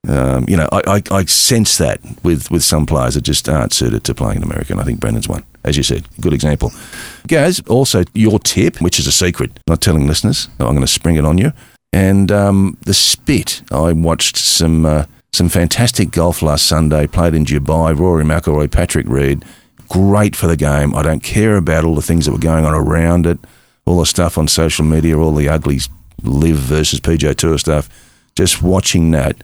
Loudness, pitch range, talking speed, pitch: -13 LUFS, 75-95 Hz, 210 wpm, 80 Hz